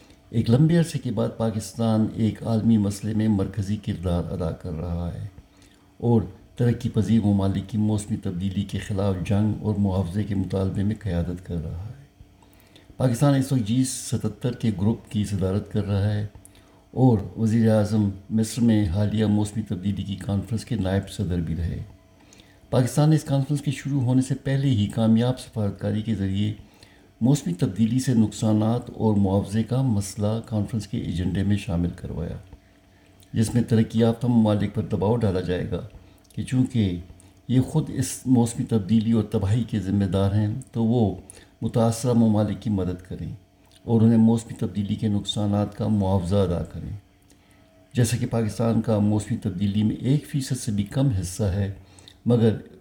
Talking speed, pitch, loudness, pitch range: 160 wpm, 105 Hz, -24 LUFS, 95-115 Hz